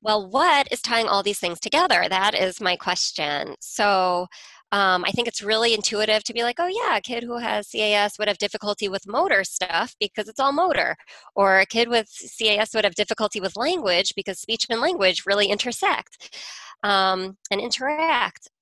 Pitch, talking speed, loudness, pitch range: 210 Hz, 185 wpm, -22 LUFS, 195-235 Hz